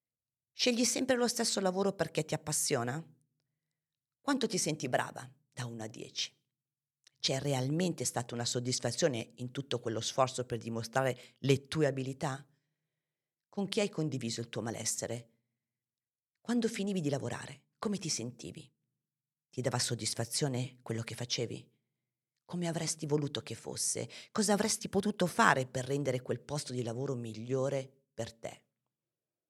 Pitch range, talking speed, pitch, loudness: 120-155 Hz, 140 wpm, 135 Hz, -34 LUFS